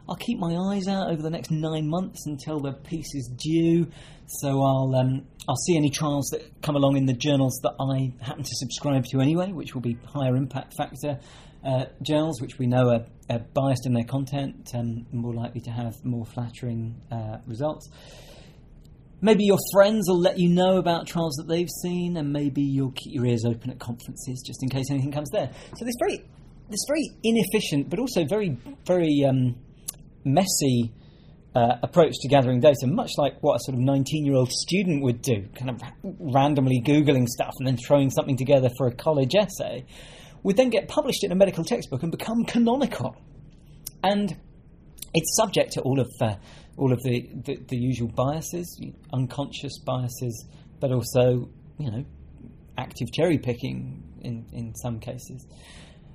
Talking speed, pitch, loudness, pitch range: 180 wpm, 140 Hz, -25 LUFS, 125-165 Hz